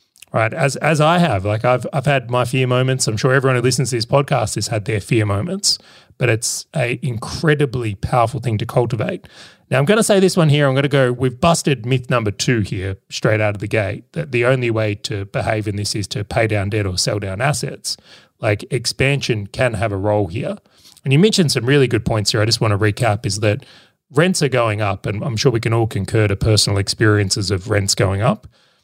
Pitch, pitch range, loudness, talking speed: 120 Hz, 105-140 Hz, -18 LUFS, 235 wpm